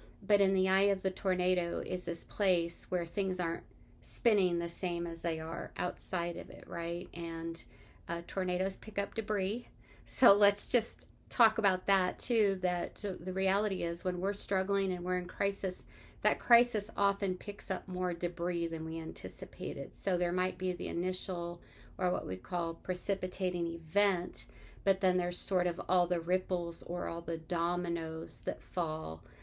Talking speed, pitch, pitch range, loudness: 170 wpm, 180 Hz, 170-195 Hz, -34 LUFS